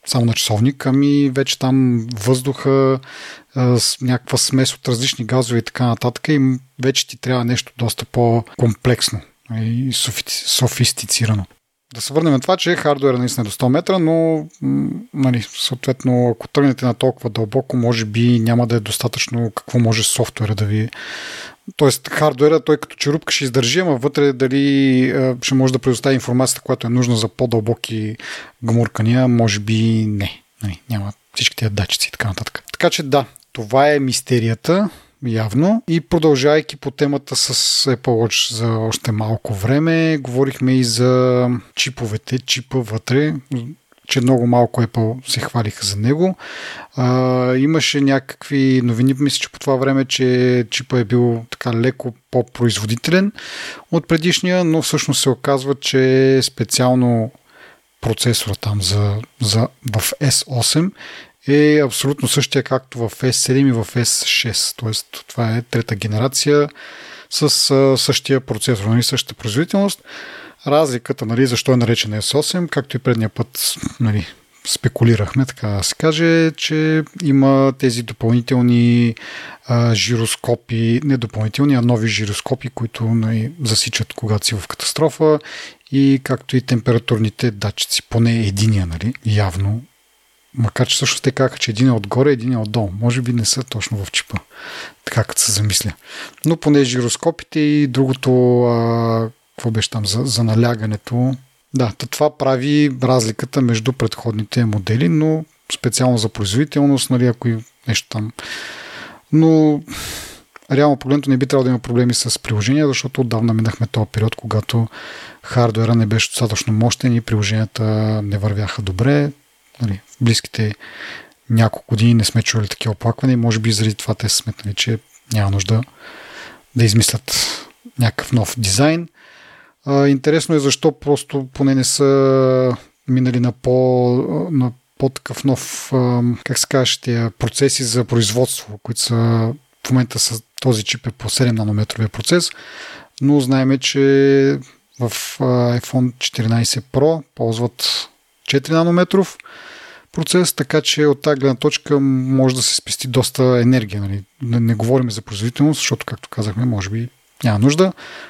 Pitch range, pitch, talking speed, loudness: 115-140 Hz, 125 Hz, 145 wpm, -17 LUFS